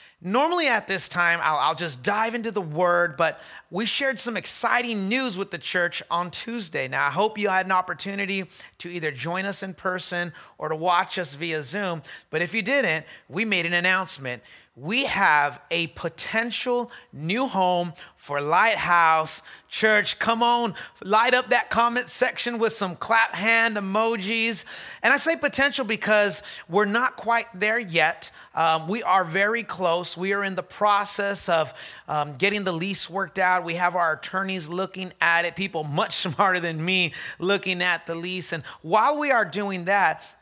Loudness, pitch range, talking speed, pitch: -23 LUFS, 170-220 Hz, 175 wpm, 190 Hz